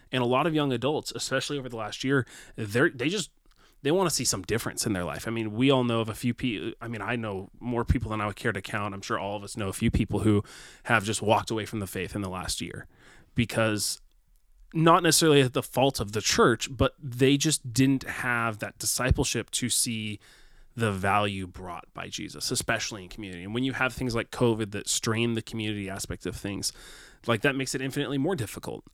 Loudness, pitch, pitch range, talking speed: -27 LUFS, 115 Hz, 105-130 Hz, 230 wpm